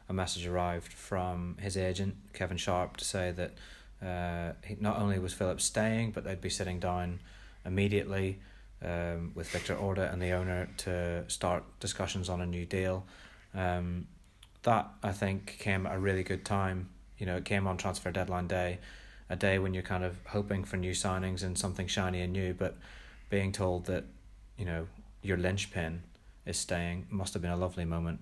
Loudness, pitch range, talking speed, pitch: -35 LUFS, 90-100 Hz, 185 wpm, 95 Hz